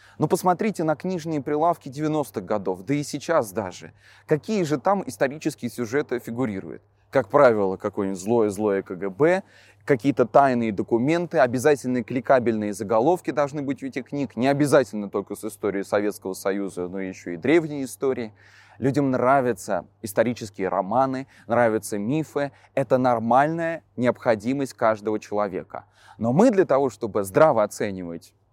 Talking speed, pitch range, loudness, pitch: 135 wpm, 105-145 Hz, -23 LUFS, 125 Hz